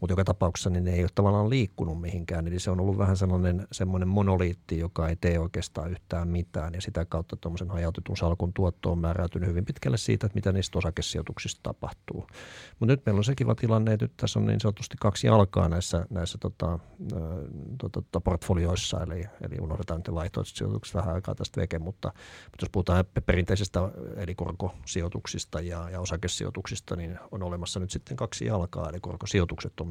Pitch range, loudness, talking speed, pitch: 85-105 Hz, -29 LUFS, 185 wpm, 90 Hz